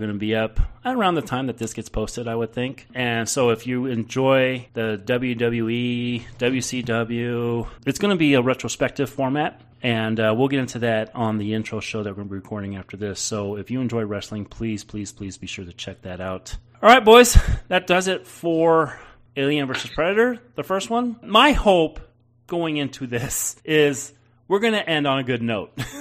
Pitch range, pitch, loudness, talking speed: 110-140 Hz, 120 Hz, -21 LUFS, 205 wpm